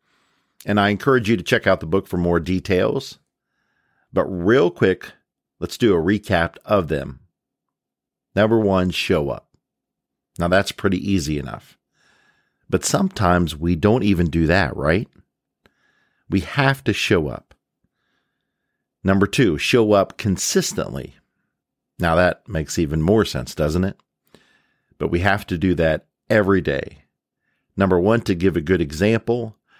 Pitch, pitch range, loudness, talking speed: 95 Hz, 85-105 Hz, -20 LUFS, 145 wpm